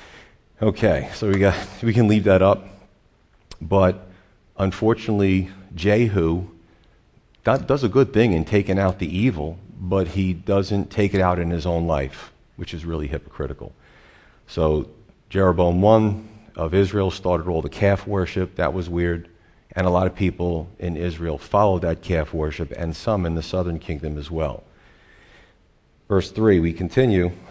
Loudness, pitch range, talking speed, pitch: -21 LUFS, 85-100 Hz, 155 wpm, 90 Hz